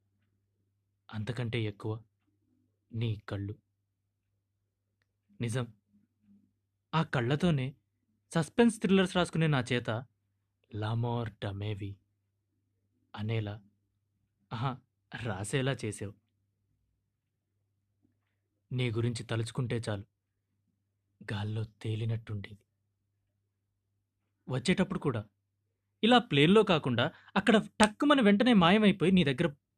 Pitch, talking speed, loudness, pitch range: 105 Hz, 70 wpm, -30 LUFS, 100-125 Hz